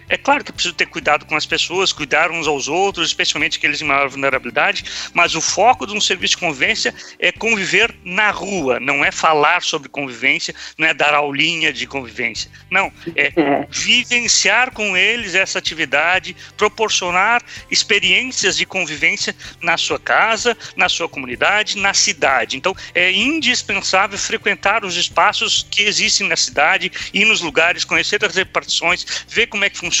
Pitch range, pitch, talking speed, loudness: 155-205 Hz, 180 Hz, 165 wpm, -15 LUFS